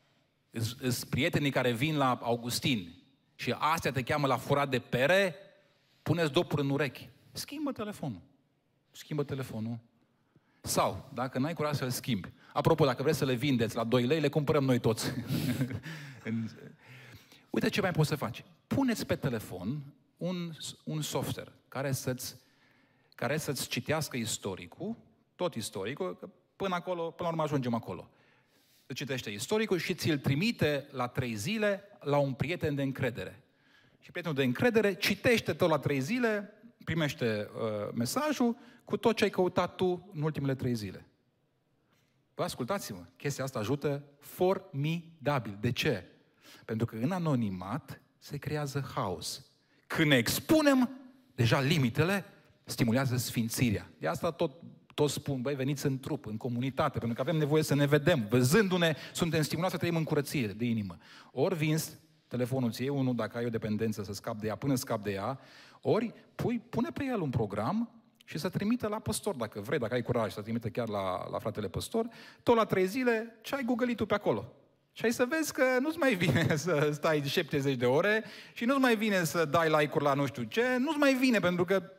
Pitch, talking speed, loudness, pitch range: 145 Hz, 170 wpm, -31 LUFS, 125-180 Hz